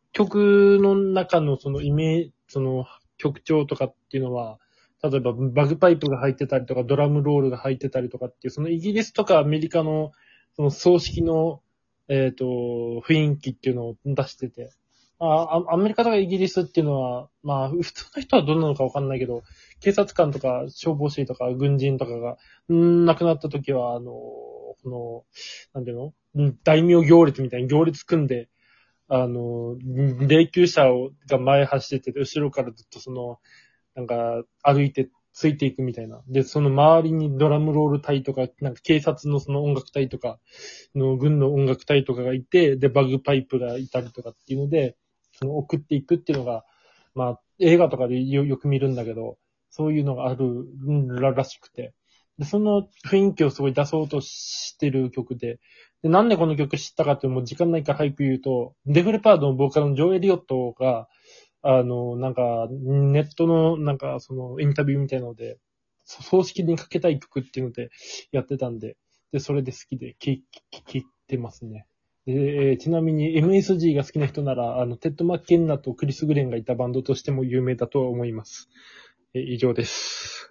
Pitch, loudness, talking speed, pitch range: 140 Hz, -22 LUFS, 370 characters per minute, 130-155 Hz